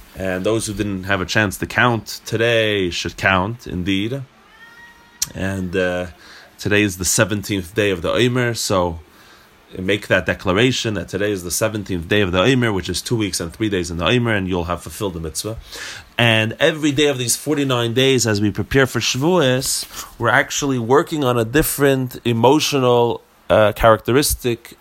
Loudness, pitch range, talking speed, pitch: -18 LUFS, 95-125 Hz, 175 wpm, 110 Hz